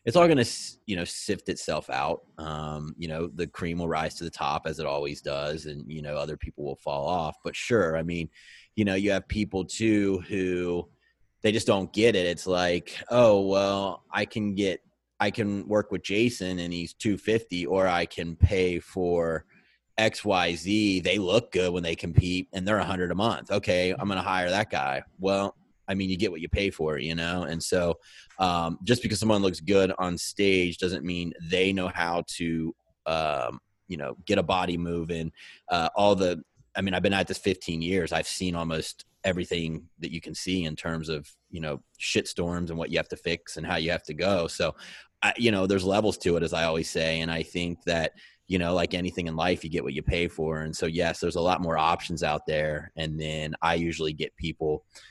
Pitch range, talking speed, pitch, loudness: 80-95 Hz, 225 wpm, 90 Hz, -27 LUFS